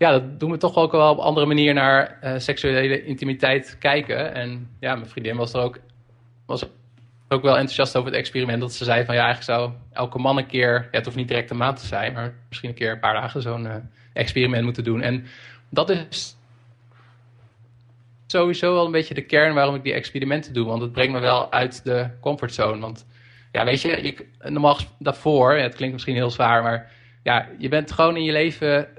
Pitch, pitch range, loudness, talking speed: 125 Hz, 120-140 Hz, -21 LUFS, 215 wpm